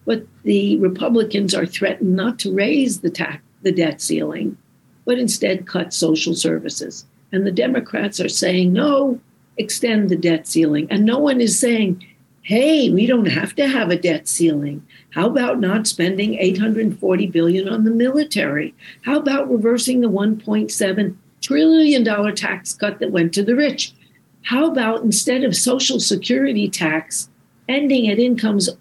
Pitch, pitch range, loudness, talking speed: 205 Hz, 180-245 Hz, -18 LUFS, 155 wpm